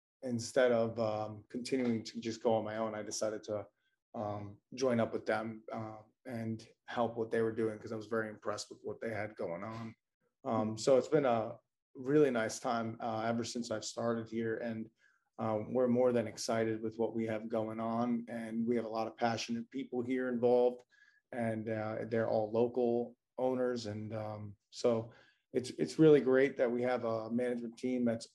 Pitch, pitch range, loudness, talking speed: 115 Hz, 110-120 Hz, -35 LUFS, 195 wpm